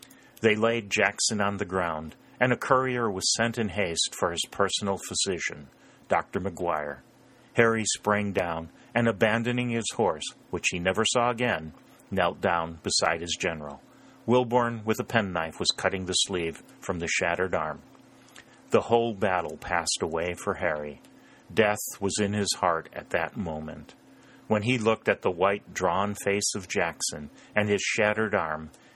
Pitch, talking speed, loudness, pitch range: 105 Hz, 160 wpm, -27 LUFS, 90-115 Hz